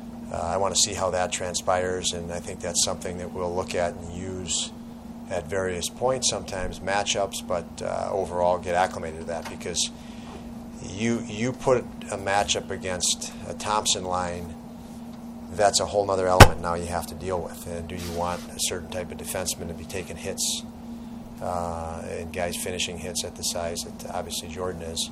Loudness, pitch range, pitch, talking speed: -26 LUFS, 85-115 Hz, 90 Hz, 185 wpm